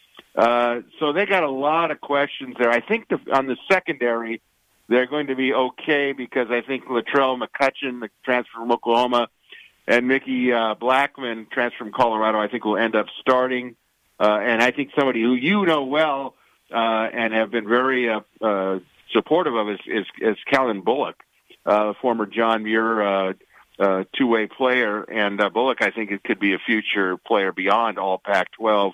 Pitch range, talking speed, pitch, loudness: 110-130 Hz, 185 wpm, 120 Hz, -21 LUFS